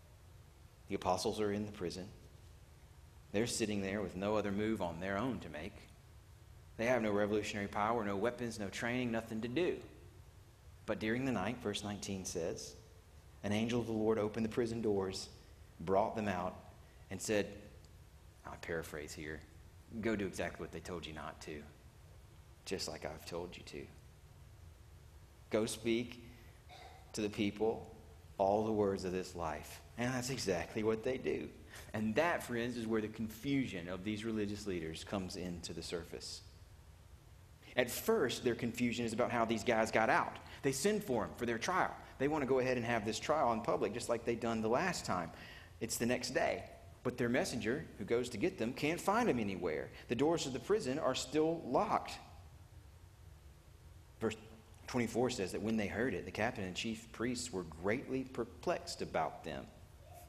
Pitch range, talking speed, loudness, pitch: 90-115 Hz, 180 wpm, -38 LUFS, 105 Hz